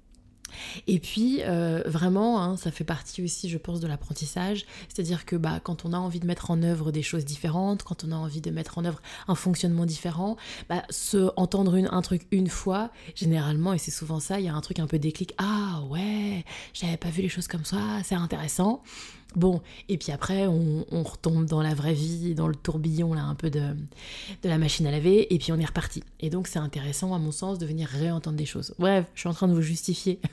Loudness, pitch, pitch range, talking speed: -28 LUFS, 170 Hz, 160-185 Hz, 235 wpm